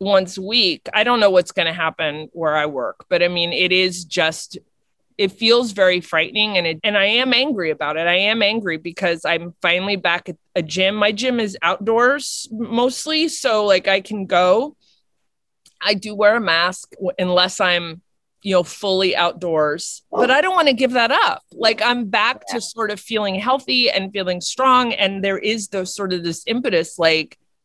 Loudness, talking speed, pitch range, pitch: -18 LUFS, 190 wpm, 175-225 Hz, 195 Hz